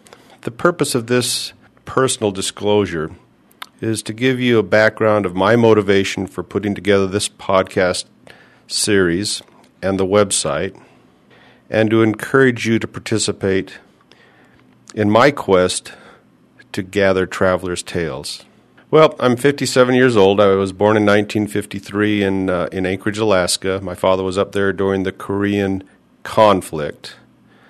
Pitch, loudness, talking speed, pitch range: 105 Hz, -17 LUFS, 130 wpm, 95-115 Hz